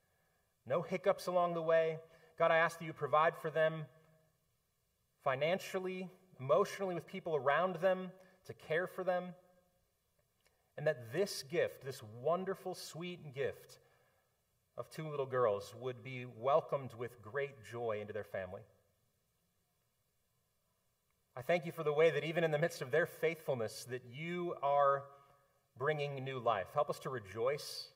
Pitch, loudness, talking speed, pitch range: 160 Hz, -37 LUFS, 145 wpm, 140-180 Hz